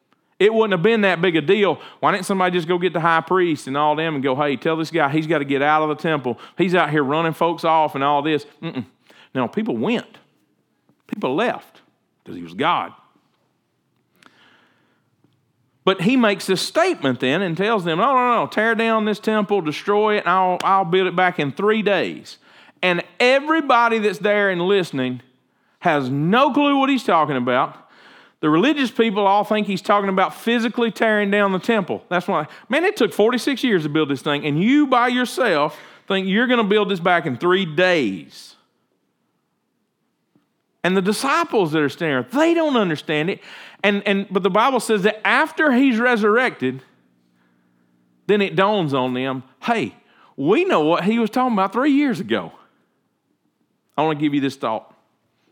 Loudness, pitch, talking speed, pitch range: -19 LUFS, 190 Hz, 190 wpm, 155-225 Hz